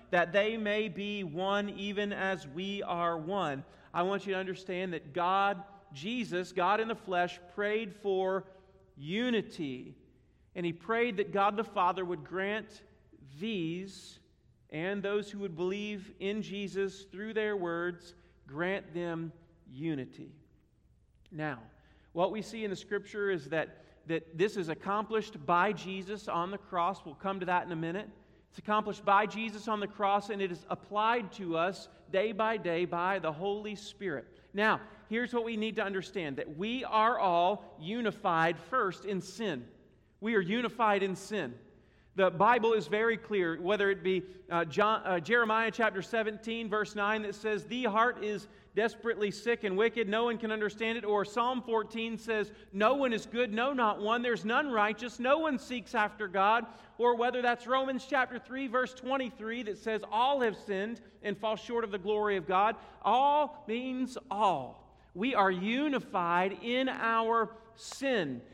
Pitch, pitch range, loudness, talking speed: 205 Hz, 185-225 Hz, -32 LUFS, 165 wpm